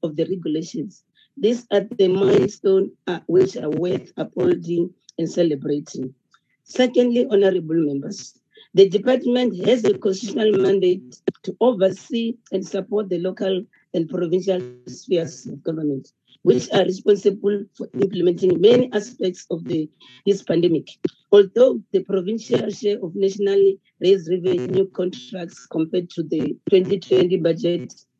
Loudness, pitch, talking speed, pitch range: -20 LUFS, 190 Hz, 125 wpm, 175-205 Hz